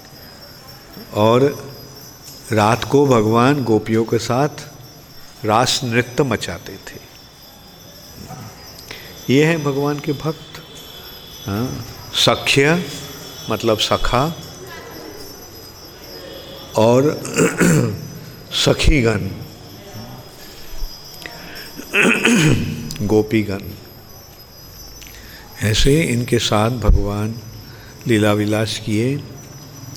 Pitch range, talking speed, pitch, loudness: 110-140 Hz, 60 wpm, 120 Hz, -17 LUFS